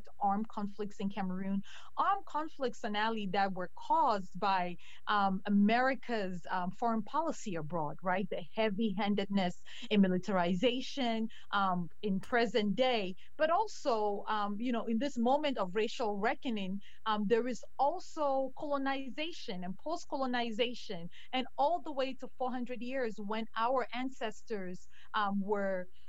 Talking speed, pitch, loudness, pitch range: 135 wpm, 220 Hz, -35 LUFS, 200-255 Hz